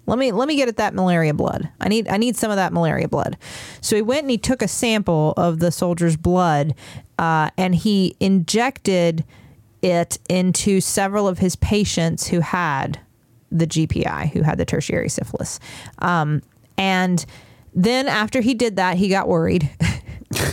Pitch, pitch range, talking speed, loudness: 180 Hz, 160-210 Hz, 170 wpm, -20 LUFS